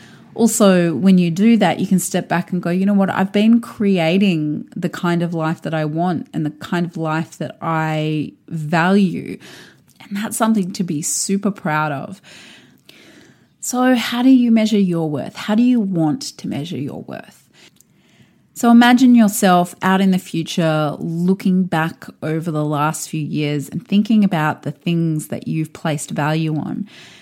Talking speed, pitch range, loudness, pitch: 175 wpm, 155-205 Hz, -17 LUFS, 180 Hz